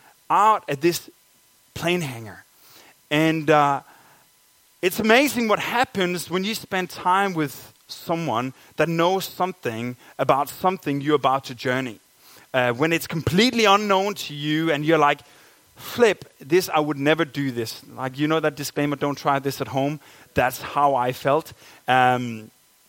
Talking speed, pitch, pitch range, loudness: 150 wpm, 150 Hz, 135-180 Hz, -22 LUFS